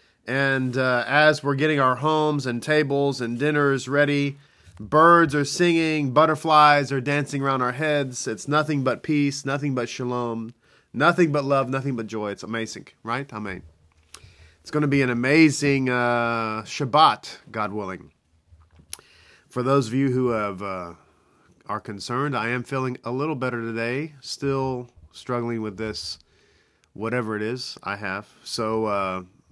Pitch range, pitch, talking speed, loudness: 110-145 Hz, 130 Hz, 155 wpm, -23 LUFS